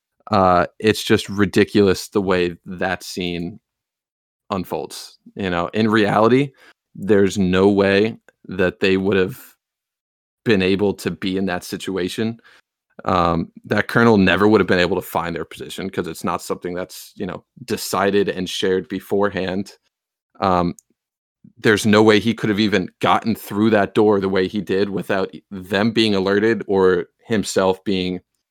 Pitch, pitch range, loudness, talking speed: 100 Hz, 95-105 Hz, -19 LUFS, 155 wpm